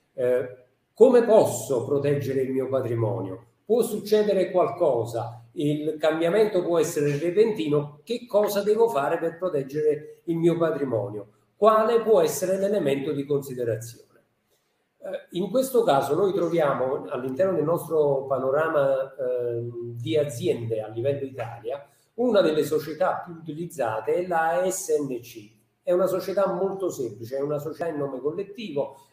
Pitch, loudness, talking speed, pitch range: 155 Hz, -24 LUFS, 135 wpm, 135-190 Hz